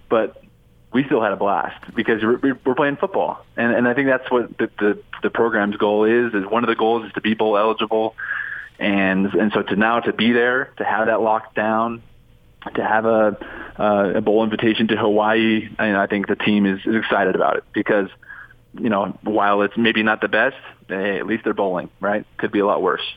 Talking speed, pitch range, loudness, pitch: 220 wpm, 105-115 Hz, -19 LUFS, 110 Hz